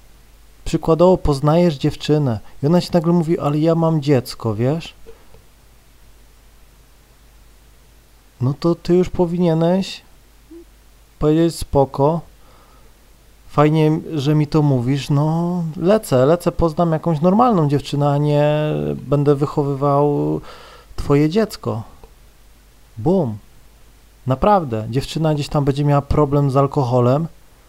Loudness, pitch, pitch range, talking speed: -17 LUFS, 150 Hz, 140-170 Hz, 105 wpm